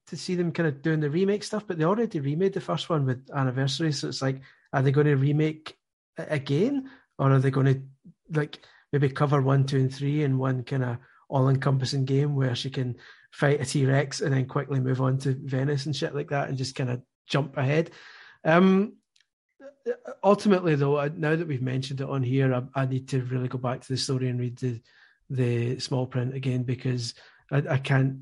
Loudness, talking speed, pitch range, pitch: -26 LUFS, 215 wpm, 130-155 Hz, 140 Hz